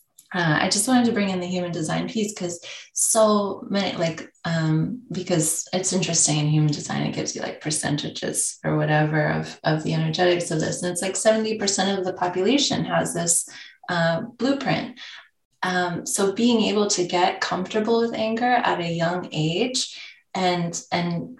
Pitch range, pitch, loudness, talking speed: 165-215 Hz, 180 Hz, -23 LUFS, 170 wpm